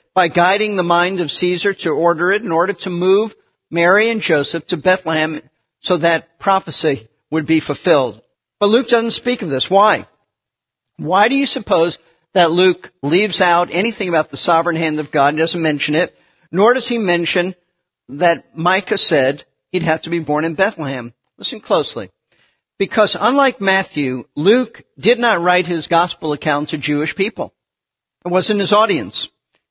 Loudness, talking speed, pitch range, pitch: -16 LUFS, 170 wpm, 160-195 Hz, 175 Hz